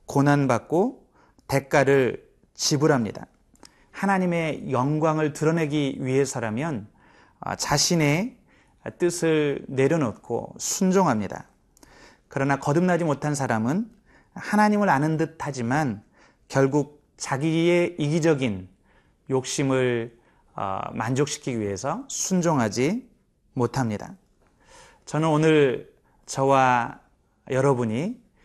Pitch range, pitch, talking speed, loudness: 130-165 Hz, 145 Hz, 215 characters per minute, -24 LUFS